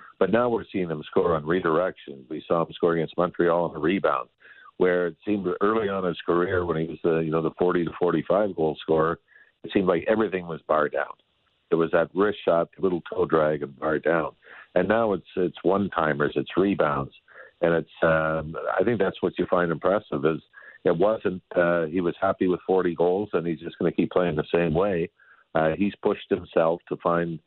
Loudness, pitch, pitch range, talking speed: -25 LUFS, 85 Hz, 80-90 Hz, 220 wpm